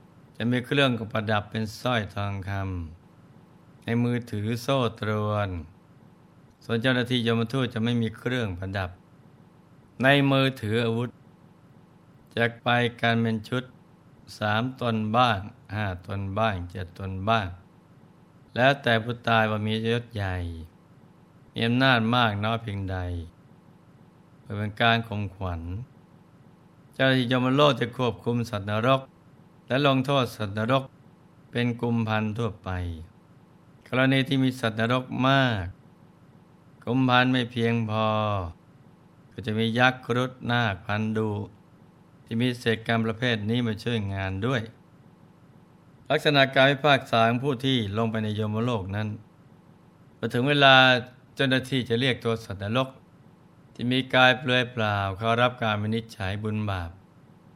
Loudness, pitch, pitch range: -25 LUFS, 120 Hz, 110-130 Hz